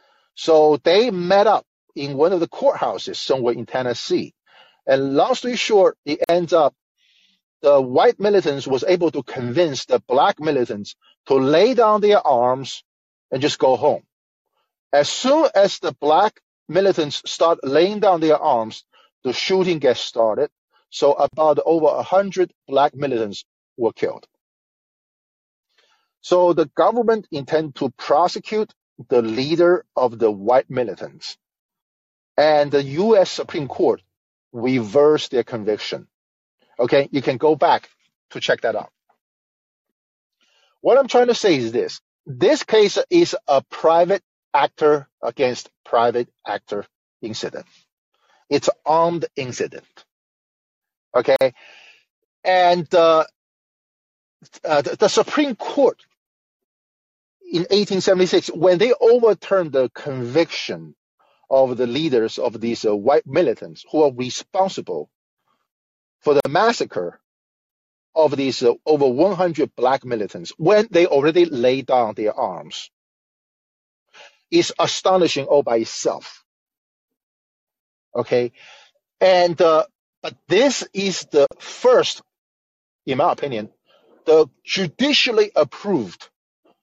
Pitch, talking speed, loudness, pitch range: 165 Hz, 120 wpm, -19 LUFS, 135-205 Hz